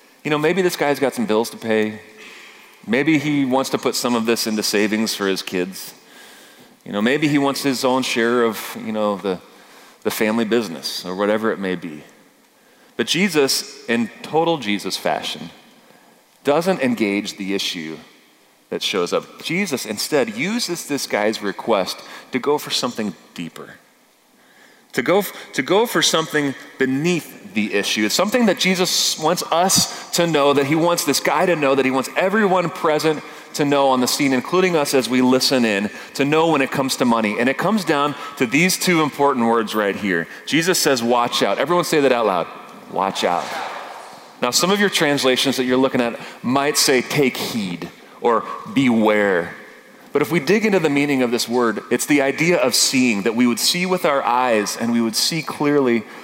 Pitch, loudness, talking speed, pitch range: 135 Hz, -19 LUFS, 190 wpm, 115-160 Hz